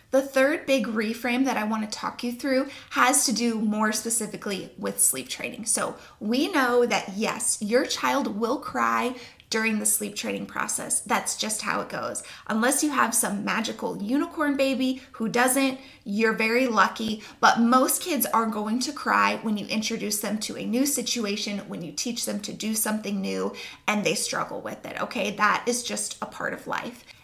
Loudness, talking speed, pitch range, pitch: -25 LUFS, 190 wpm, 210-260 Hz, 225 Hz